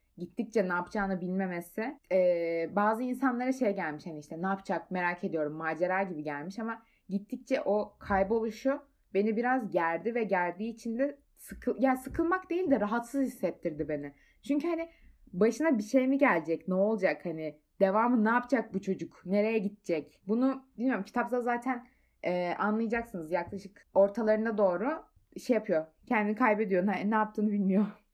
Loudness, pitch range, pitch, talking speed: -31 LUFS, 180-245 Hz, 210 Hz, 150 wpm